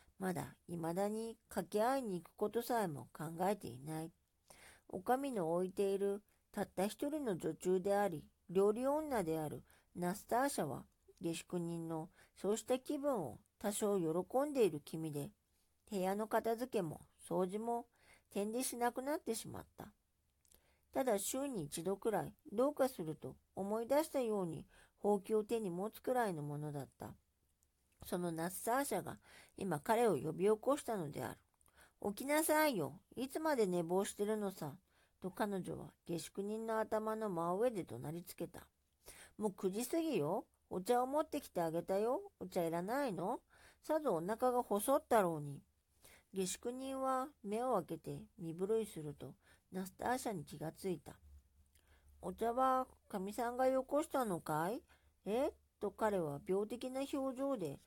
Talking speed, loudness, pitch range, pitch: 290 characters per minute, -40 LUFS, 165-240 Hz, 200 Hz